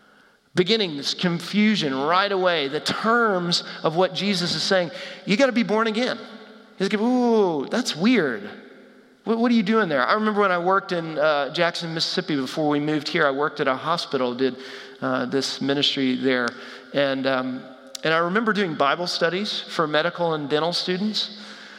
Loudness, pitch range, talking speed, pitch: -22 LUFS, 145-205 Hz, 180 wpm, 175 Hz